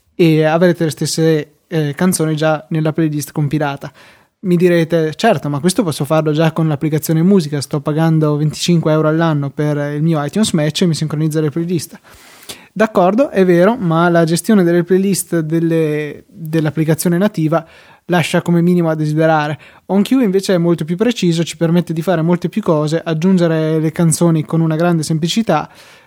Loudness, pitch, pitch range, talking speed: -15 LUFS, 165 Hz, 155-175 Hz, 165 wpm